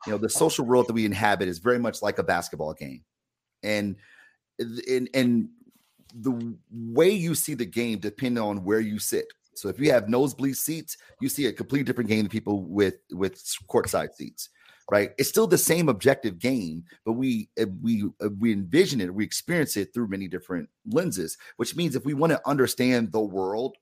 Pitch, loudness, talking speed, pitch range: 115 Hz, -26 LUFS, 195 wpm, 105-130 Hz